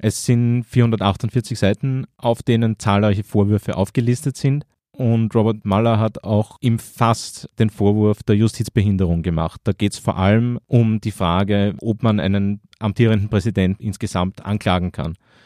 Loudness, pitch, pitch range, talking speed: -19 LUFS, 110 Hz, 100-115 Hz, 145 wpm